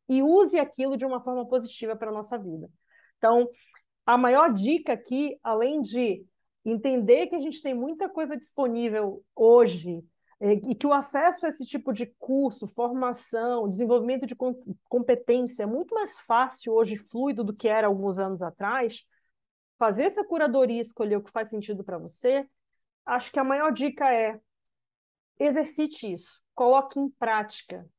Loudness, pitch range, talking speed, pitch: -26 LUFS, 220-275 Hz, 155 wpm, 245 Hz